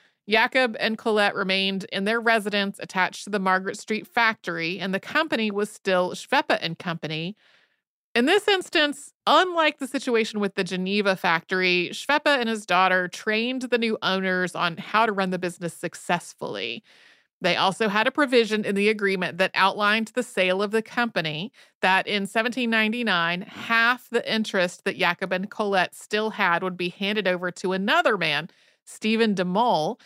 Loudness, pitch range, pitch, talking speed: -23 LUFS, 185-230 Hz, 205 Hz, 165 wpm